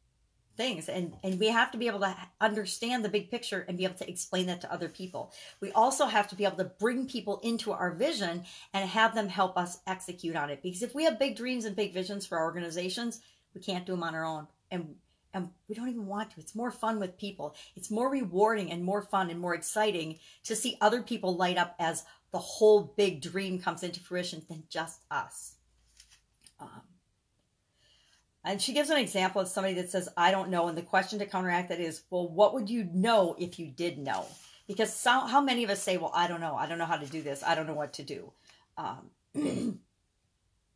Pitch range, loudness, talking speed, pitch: 170-215 Hz, -31 LUFS, 225 wpm, 190 Hz